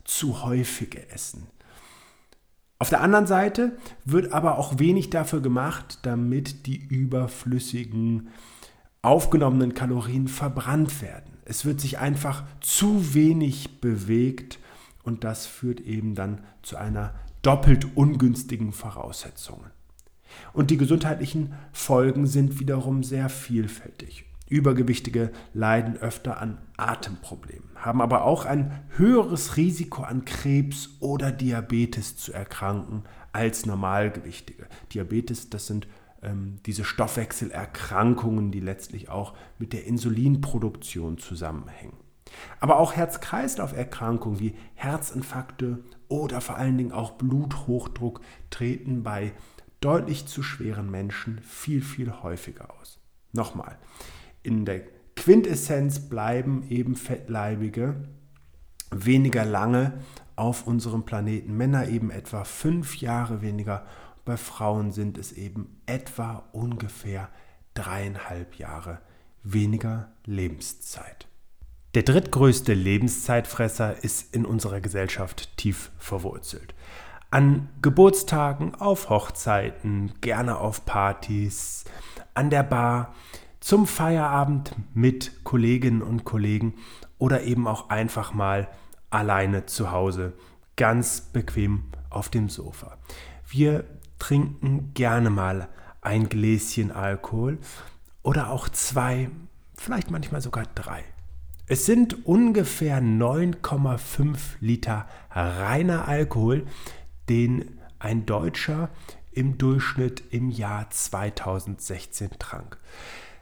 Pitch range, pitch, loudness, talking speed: 105-135 Hz, 120 Hz, -25 LUFS, 105 wpm